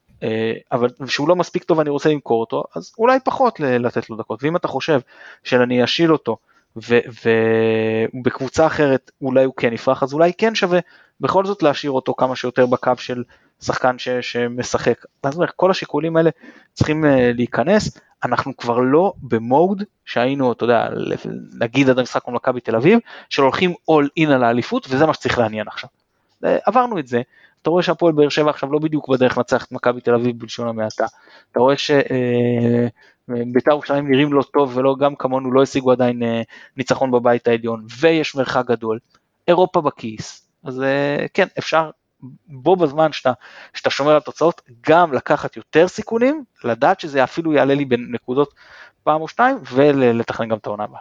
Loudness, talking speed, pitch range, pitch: -18 LUFS, 170 wpm, 120-155 Hz, 130 Hz